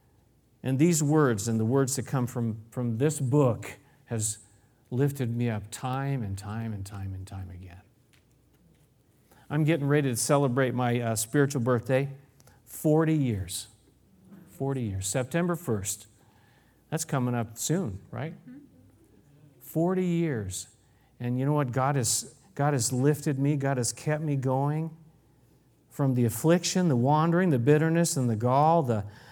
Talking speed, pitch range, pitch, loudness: 145 wpm, 115-145 Hz, 130 Hz, -27 LUFS